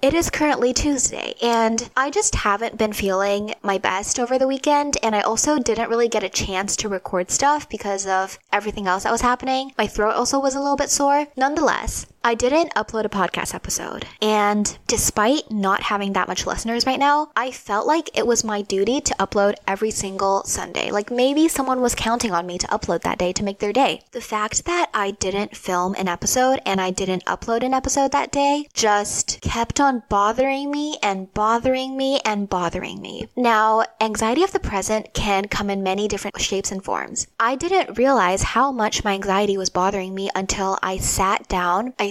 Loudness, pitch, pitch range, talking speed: -21 LUFS, 220 Hz, 195-265 Hz, 200 wpm